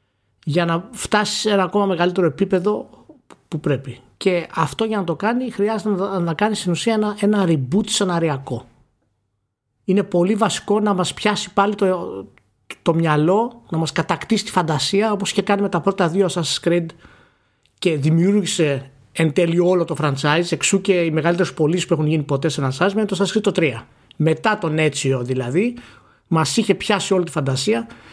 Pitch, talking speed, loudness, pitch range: 175 Hz, 175 wpm, -19 LUFS, 155-205 Hz